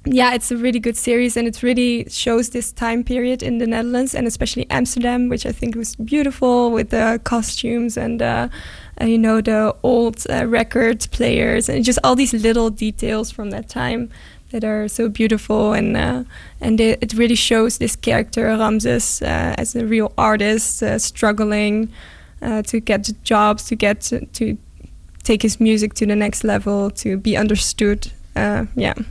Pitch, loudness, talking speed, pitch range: 225 Hz, -18 LUFS, 175 wpm, 210-235 Hz